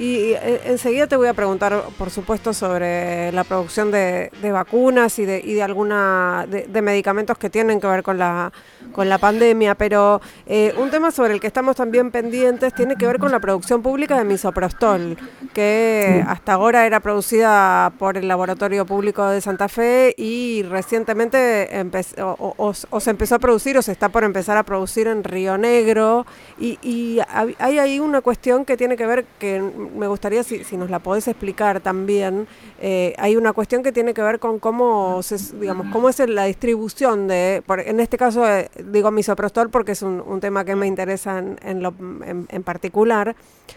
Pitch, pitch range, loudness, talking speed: 210 Hz, 195-235 Hz, -19 LUFS, 190 wpm